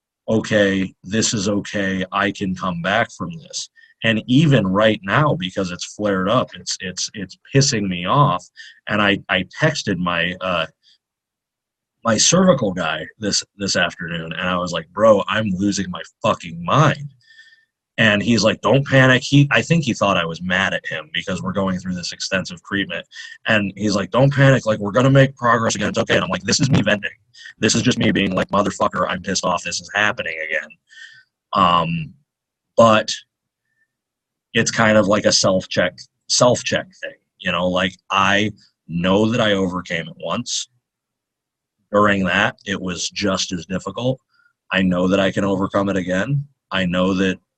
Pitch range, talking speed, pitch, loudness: 95-135 Hz, 175 wpm, 105 Hz, -18 LUFS